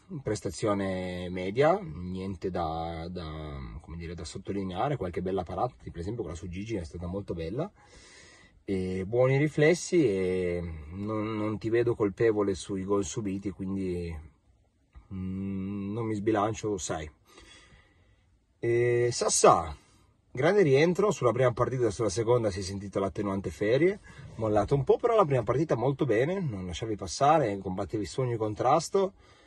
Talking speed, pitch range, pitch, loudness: 145 wpm, 95-120 Hz, 100 Hz, -29 LUFS